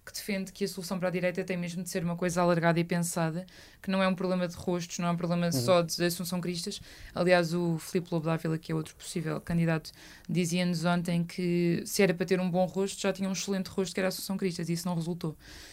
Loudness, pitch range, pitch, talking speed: -30 LUFS, 170-190 Hz, 180 Hz, 250 wpm